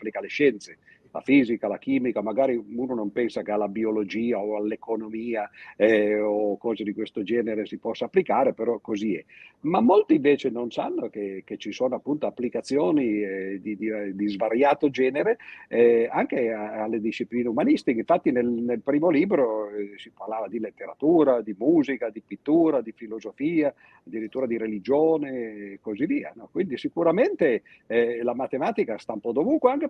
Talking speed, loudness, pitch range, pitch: 170 wpm, -25 LUFS, 105-135 Hz, 115 Hz